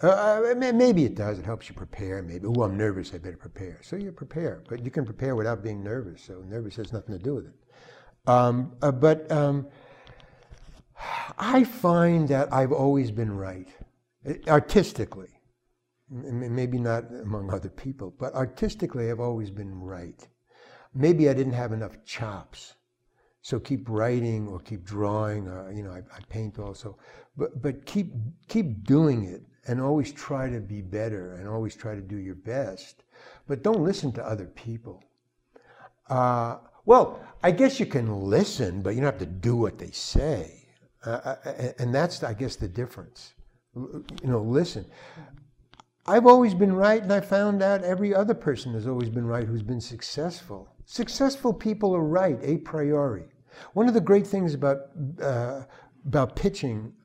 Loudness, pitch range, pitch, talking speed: -26 LUFS, 110-150 Hz, 125 Hz, 165 wpm